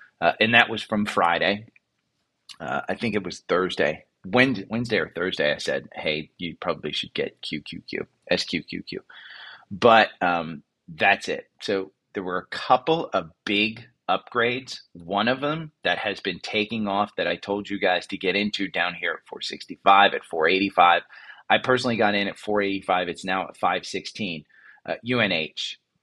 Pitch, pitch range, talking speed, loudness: 105 Hz, 95-120 Hz, 180 wpm, -24 LUFS